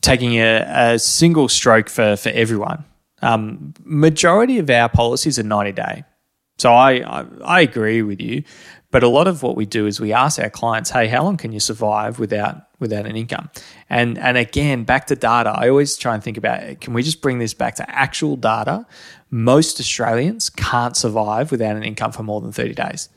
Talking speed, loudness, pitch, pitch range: 200 wpm, -17 LUFS, 115 Hz, 110-130 Hz